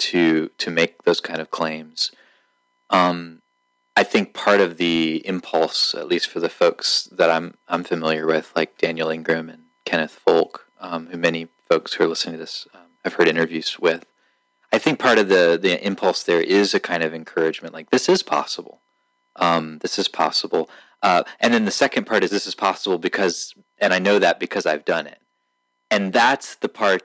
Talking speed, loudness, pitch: 195 wpm, -20 LUFS, 85 Hz